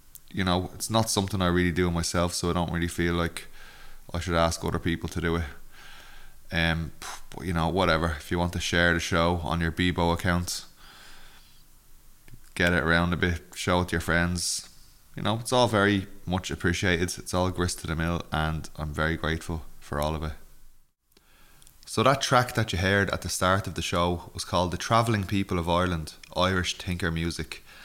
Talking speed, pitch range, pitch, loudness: 200 wpm, 85-90 Hz, 85 Hz, -27 LUFS